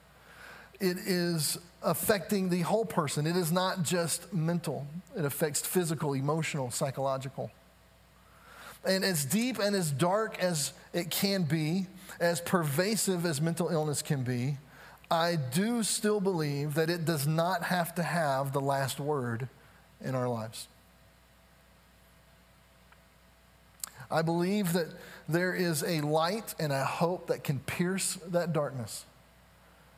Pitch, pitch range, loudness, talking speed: 165 Hz, 140-180 Hz, -31 LUFS, 130 wpm